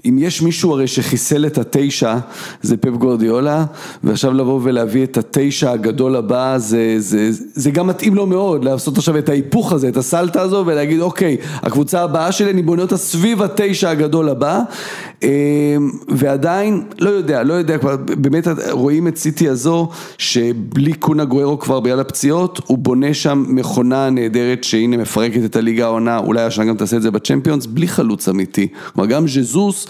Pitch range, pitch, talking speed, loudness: 125-165 Hz, 140 Hz, 170 wpm, -15 LUFS